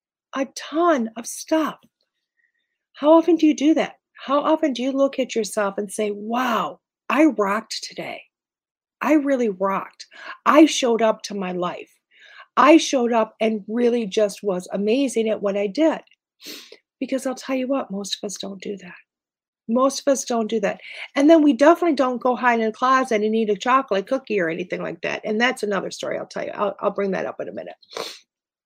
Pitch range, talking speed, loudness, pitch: 210-285 Hz, 200 wpm, -21 LUFS, 245 Hz